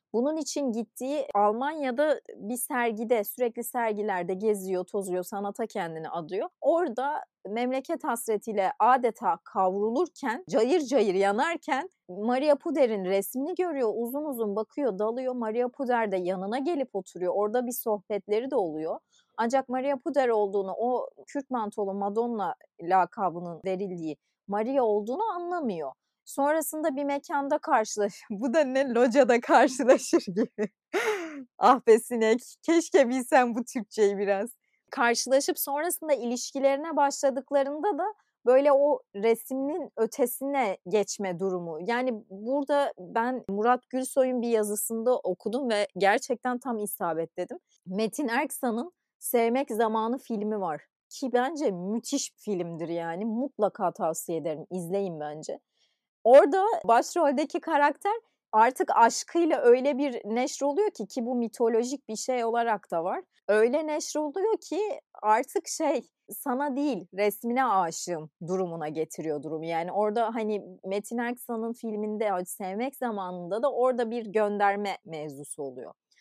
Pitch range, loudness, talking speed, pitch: 205-280 Hz, -28 LUFS, 125 wpm, 235 Hz